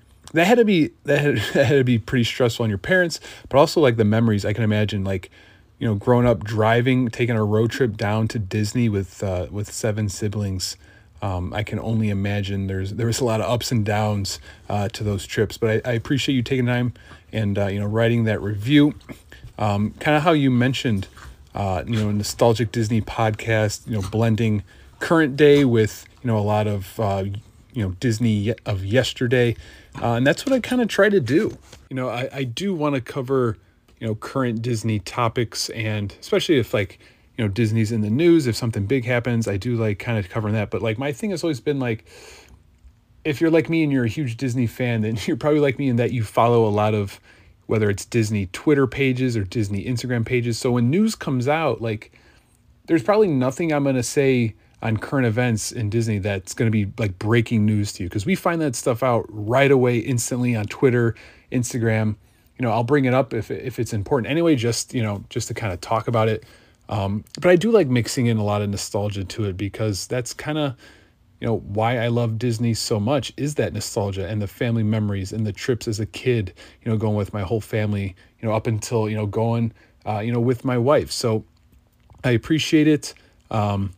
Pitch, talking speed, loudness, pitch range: 115 Hz, 220 wpm, -22 LUFS, 105-125 Hz